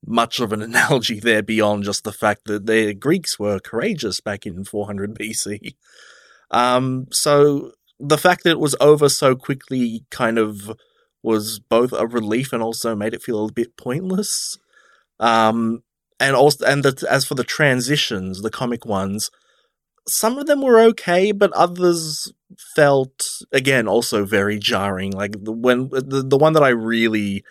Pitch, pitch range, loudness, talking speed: 120 Hz, 110-145 Hz, -18 LUFS, 165 wpm